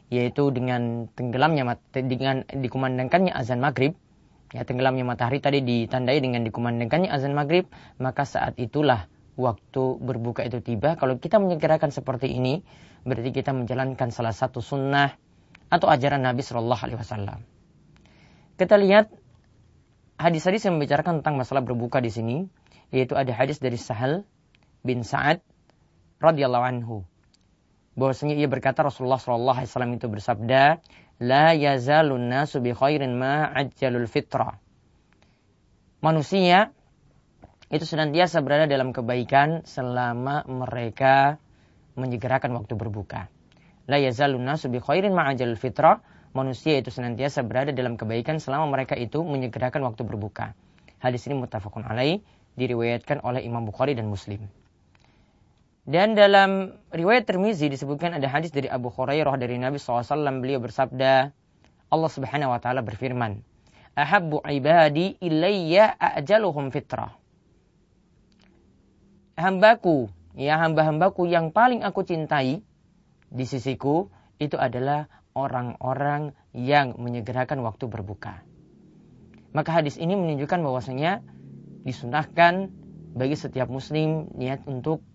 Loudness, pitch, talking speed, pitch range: -24 LUFS, 130 Hz, 120 wpm, 120-150 Hz